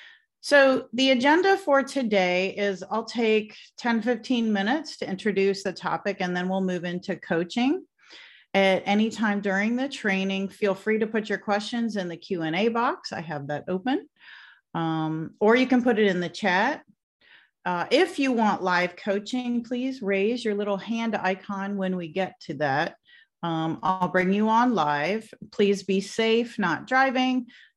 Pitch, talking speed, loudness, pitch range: 205 Hz, 165 wpm, -25 LUFS, 190-245 Hz